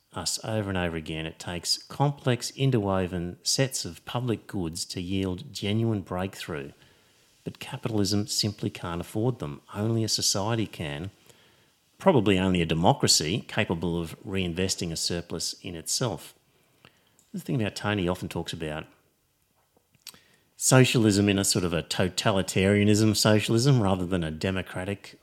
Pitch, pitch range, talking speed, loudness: 95 Hz, 90-110 Hz, 140 wpm, -26 LUFS